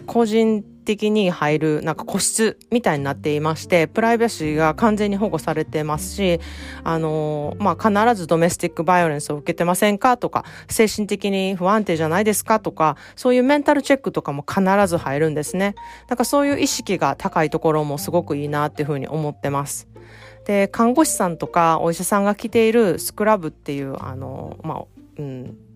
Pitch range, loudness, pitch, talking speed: 150-215 Hz, -20 LUFS, 170 Hz, 405 characters per minute